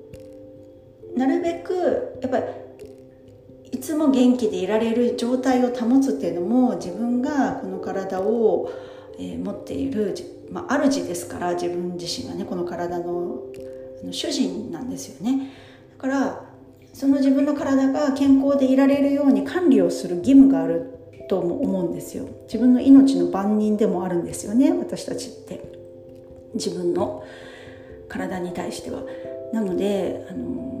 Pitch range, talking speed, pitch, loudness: 175-275 Hz, 270 characters per minute, 235 Hz, -22 LUFS